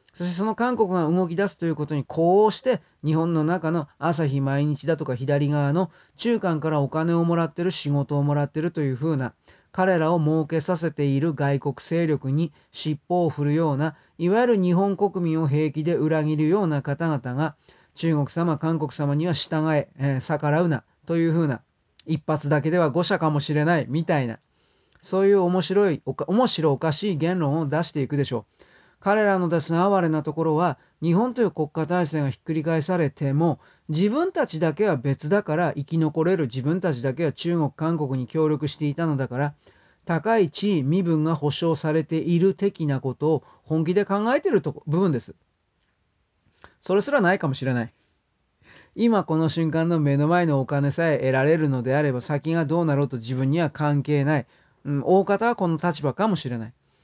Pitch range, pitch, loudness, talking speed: 145-175 Hz, 160 Hz, -23 LUFS, 360 characters per minute